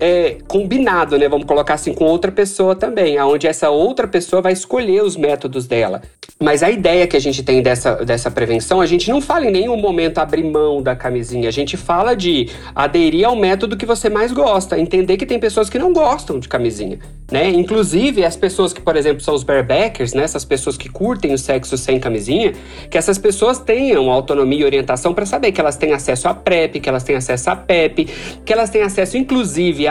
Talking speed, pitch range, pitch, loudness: 210 wpm, 140-215 Hz, 175 Hz, -15 LUFS